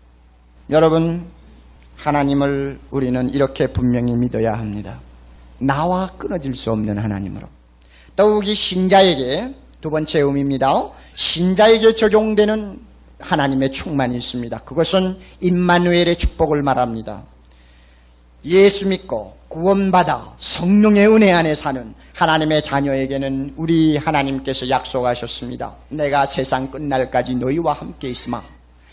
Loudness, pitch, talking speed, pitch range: -17 LUFS, 140 Hz, 290 characters per minute, 120-175 Hz